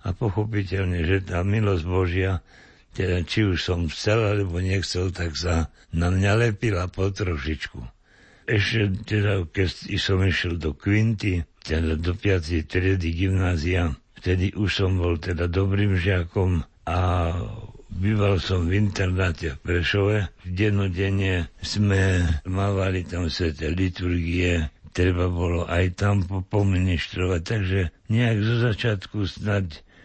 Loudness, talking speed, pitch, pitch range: -24 LUFS, 125 wpm, 95 Hz, 85-100 Hz